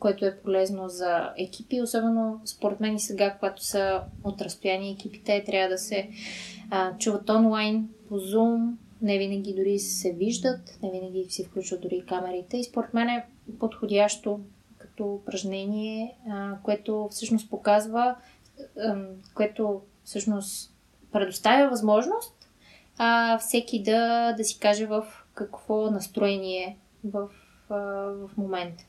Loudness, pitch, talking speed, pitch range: -27 LUFS, 205 Hz, 125 wpm, 195-225 Hz